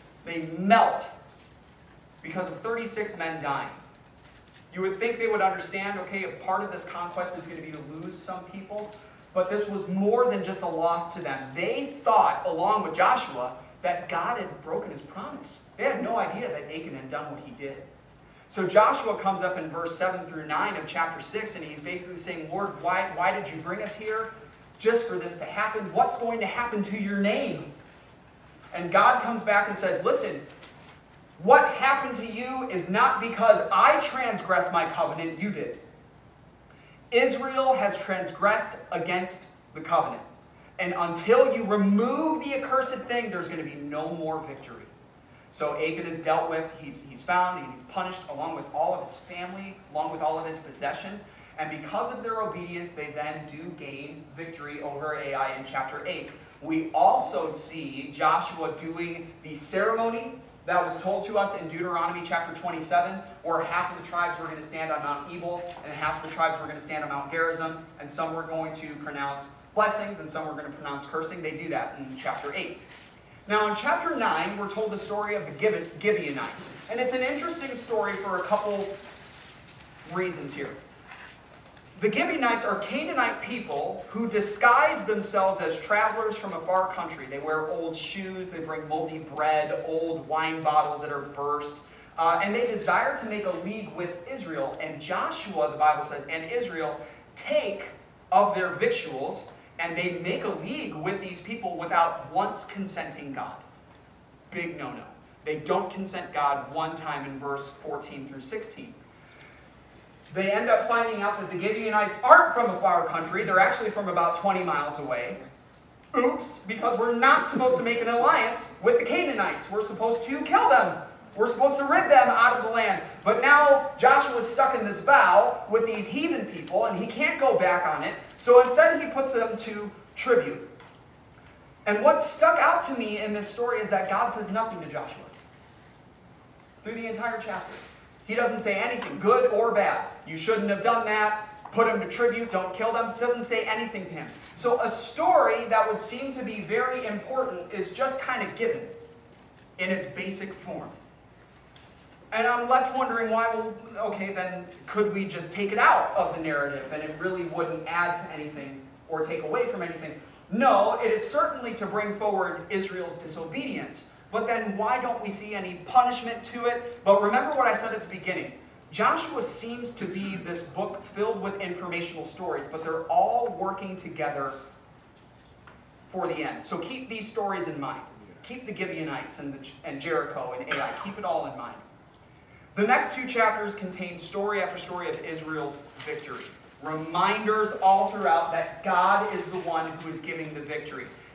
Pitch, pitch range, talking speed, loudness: 190 Hz, 160-225 Hz, 180 wpm, -27 LUFS